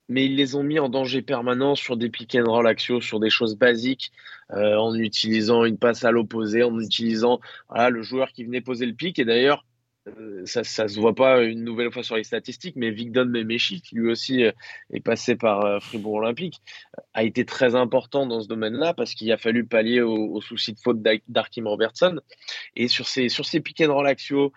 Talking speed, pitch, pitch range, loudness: 215 wpm, 120 Hz, 115-130 Hz, -23 LUFS